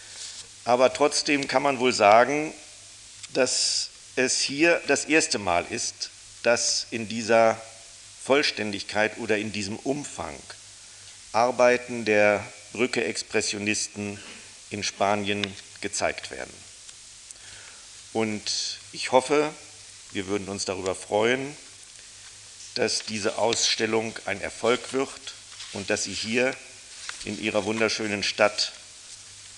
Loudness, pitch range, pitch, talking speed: -25 LUFS, 100-125 Hz, 110 Hz, 100 wpm